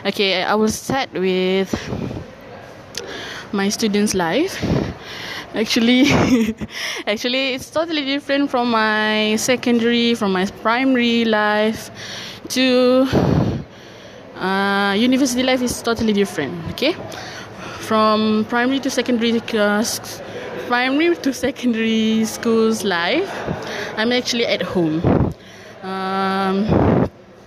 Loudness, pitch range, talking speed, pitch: -18 LUFS, 205-255 Hz, 95 wpm, 225 Hz